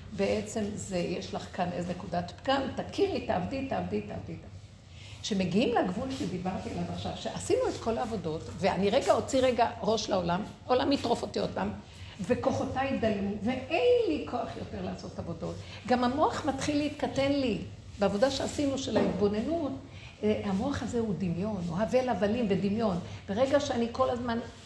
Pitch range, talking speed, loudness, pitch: 195-260 Hz, 150 wpm, -30 LUFS, 225 Hz